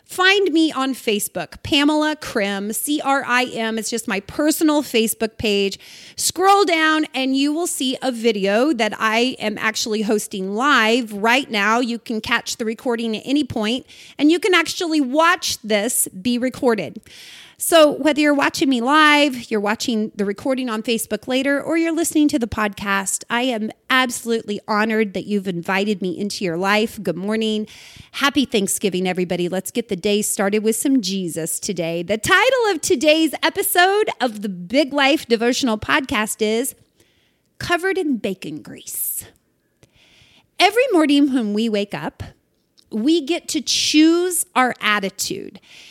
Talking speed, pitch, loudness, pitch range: 155 wpm, 240 Hz, -19 LUFS, 215-300 Hz